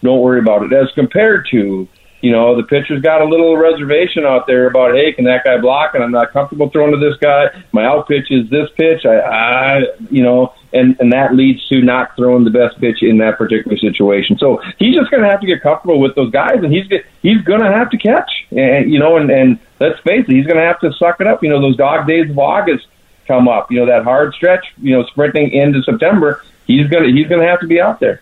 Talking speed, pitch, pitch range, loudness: 255 wpm, 140 Hz, 125-165 Hz, -11 LUFS